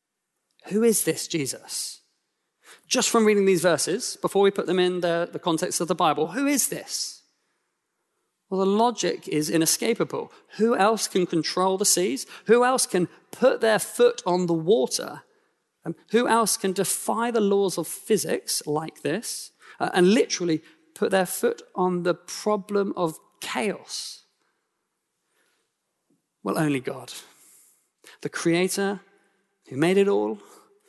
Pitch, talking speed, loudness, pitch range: 195 Hz, 145 wpm, -24 LUFS, 175-230 Hz